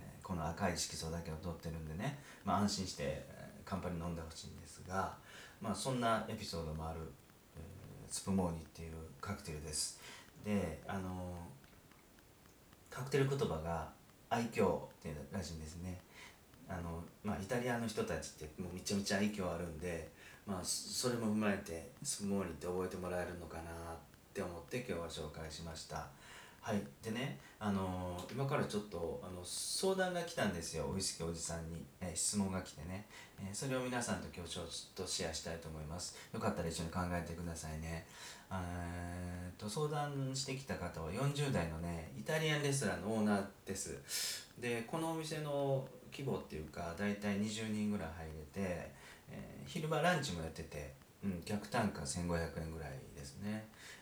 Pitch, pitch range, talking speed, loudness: 90 Hz, 80-105 Hz, 350 characters per minute, -41 LUFS